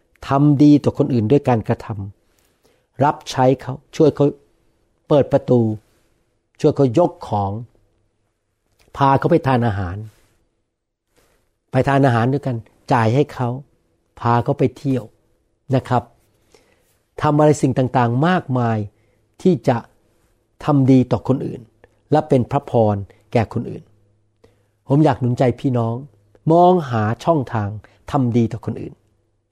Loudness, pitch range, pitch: -18 LUFS, 105-140 Hz, 120 Hz